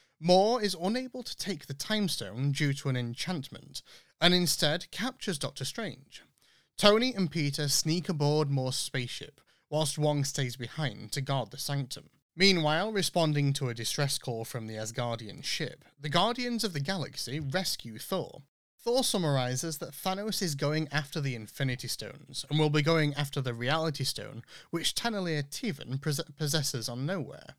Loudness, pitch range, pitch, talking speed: -30 LUFS, 135-180 Hz, 150 Hz, 160 wpm